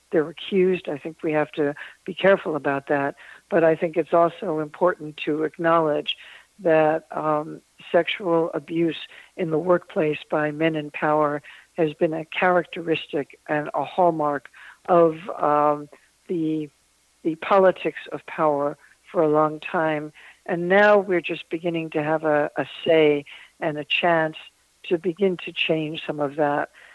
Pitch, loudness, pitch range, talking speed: 160 Hz, -23 LUFS, 150-175 Hz, 150 wpm